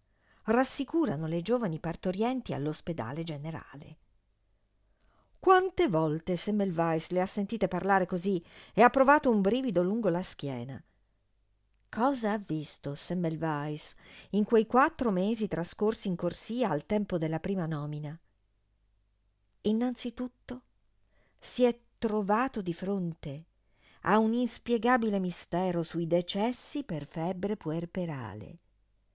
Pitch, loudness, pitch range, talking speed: 175 Hz, -30 LUFS, 145-220 Hz, 110 wpm